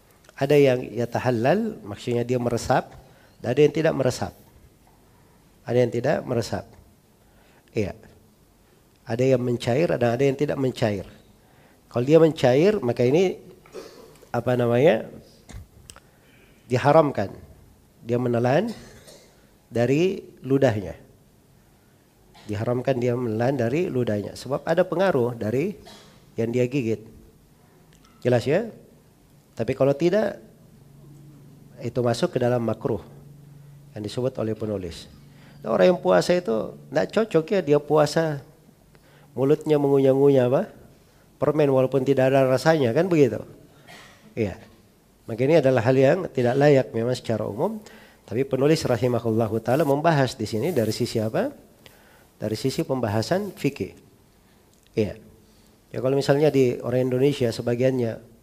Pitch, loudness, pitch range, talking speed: 125 Hz, -23 LUFS, 115-145 Hz, 120 wpm